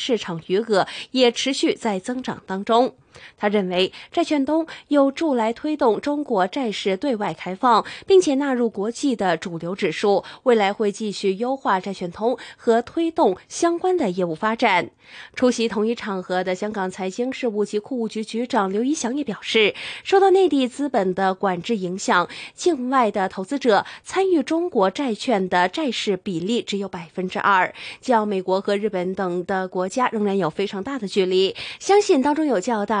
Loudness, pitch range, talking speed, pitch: -21 LUFS, 190-270 Hz, 265 characters per minute, 225 Hz